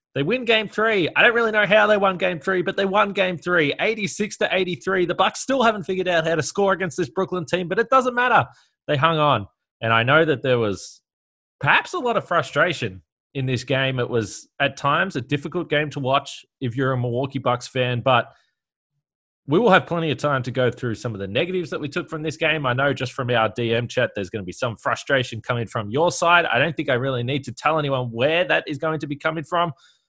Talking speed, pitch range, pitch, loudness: 245 wpm, 130-185 Hz, 150 Hz, -21 LUFS